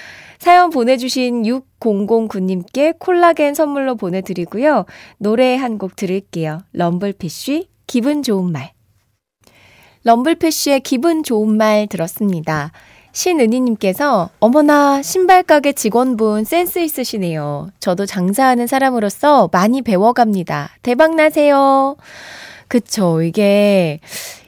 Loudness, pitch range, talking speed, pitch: -15 LUFS, 185-285 Hz, 250 characters per minute, 230 Hz